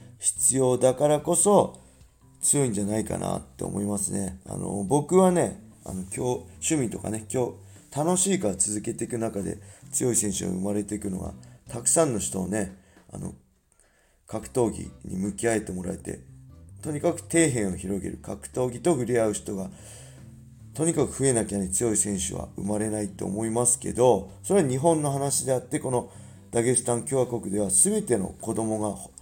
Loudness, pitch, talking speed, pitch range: -25 LUFS, 110 Hz, 335 characters per minute, 100-130 Hz